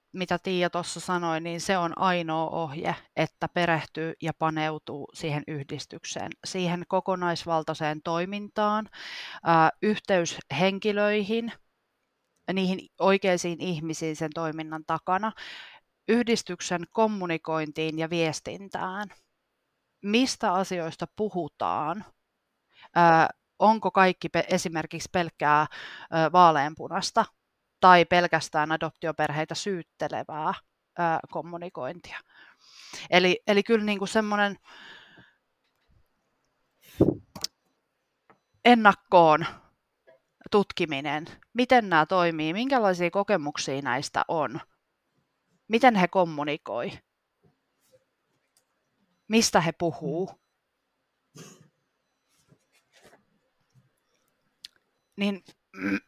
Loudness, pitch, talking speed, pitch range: -26 LUFS, 175 Hz, 70 wpm, 160-195 Hz